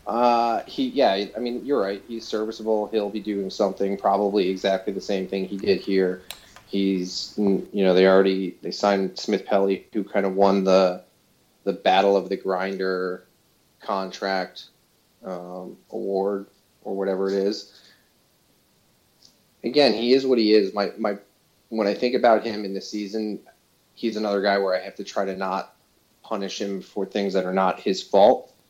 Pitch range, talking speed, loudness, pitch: 95-105 Hz, 170 wpm, -23 LUFS, 100 Hz